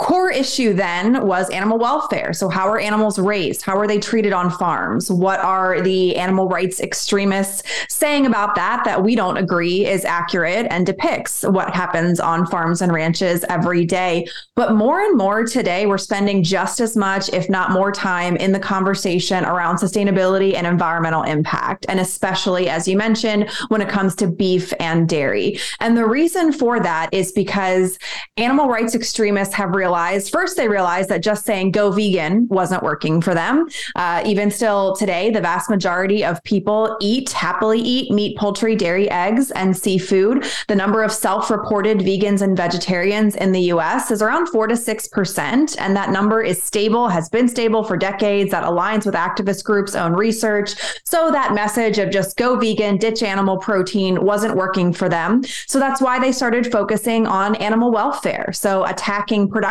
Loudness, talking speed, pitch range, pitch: -18 LUFS, 180 wpm, 185-220 Hz, 200 Hz